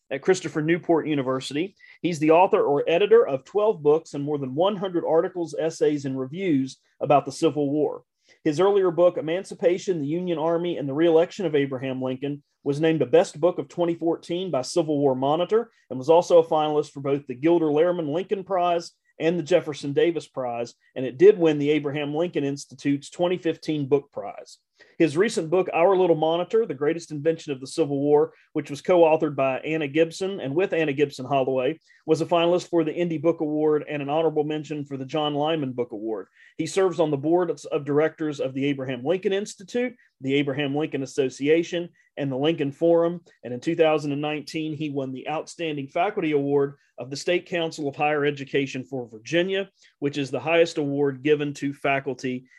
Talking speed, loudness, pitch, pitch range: 185 wpm, -24 LUFS, 155 Hz, 140-170 Hz